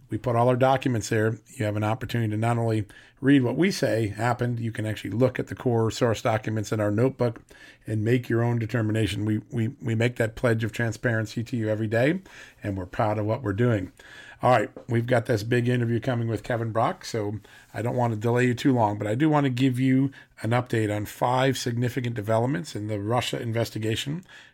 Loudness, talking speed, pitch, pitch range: -25 LUFS, 225 wpm, 115 Hz, 110-125 Hz